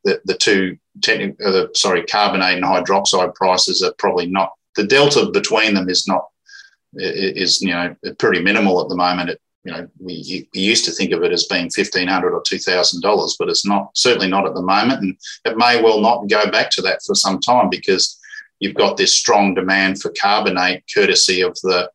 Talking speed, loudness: 200 wpm, -16 LUFS